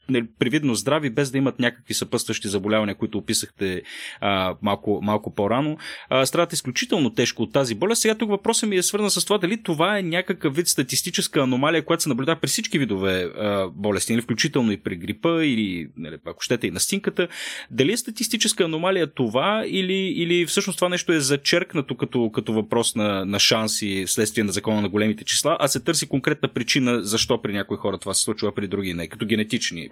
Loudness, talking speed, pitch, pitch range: -22 LUFS, 195 wpm, 130 Hz, 105-170 Hz